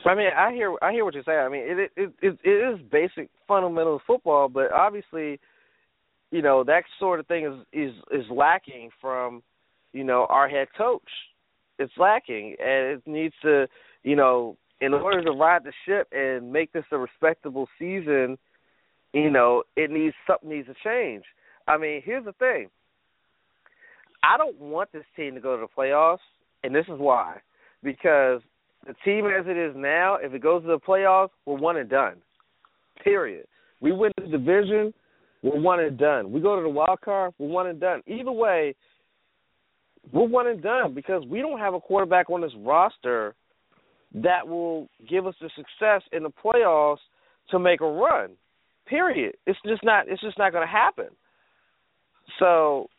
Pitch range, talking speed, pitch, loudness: 145-200 Hz, 180 wpm, 165 Hz, -24 LUFS